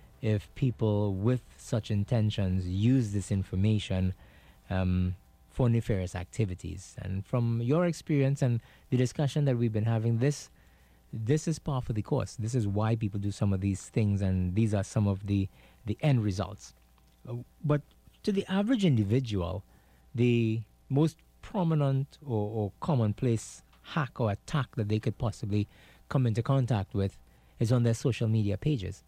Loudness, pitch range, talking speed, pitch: -30 LUFS, 95-125 Hz, 155 wpm, 110 Hz